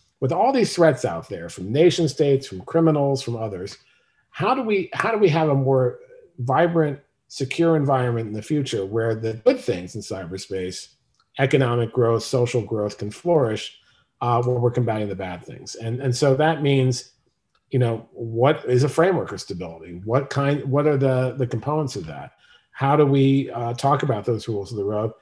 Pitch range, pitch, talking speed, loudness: 115-145 Hz, 130 Hz, 190 wpm, -22 LUFS